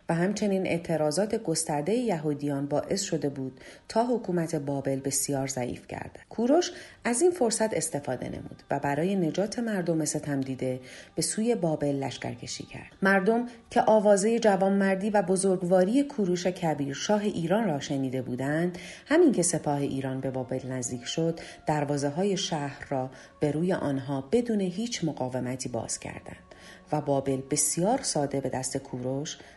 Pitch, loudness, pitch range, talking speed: 160 Hz, -28 LUFS, 140-195 Hz, 145 wpm